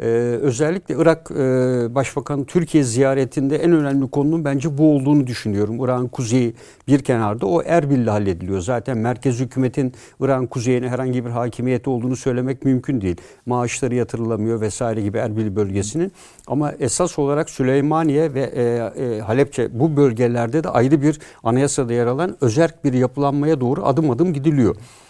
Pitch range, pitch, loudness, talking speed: 120-145 Hz, 130 Hz, -19 LUFS, 140 wpm